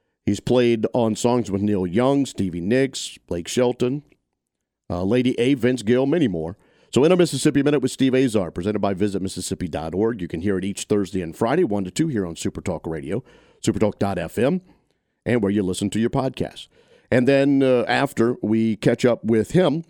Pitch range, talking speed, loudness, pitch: 95-125 Hz, 185 wpm, -21 LUFS, 110 Hz